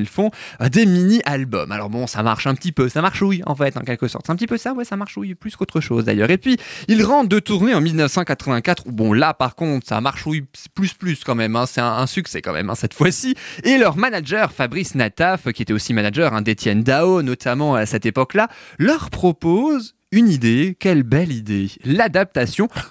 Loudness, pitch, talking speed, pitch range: -18 LUFS, 155 Hz, 225 wpm, 125-195 Hz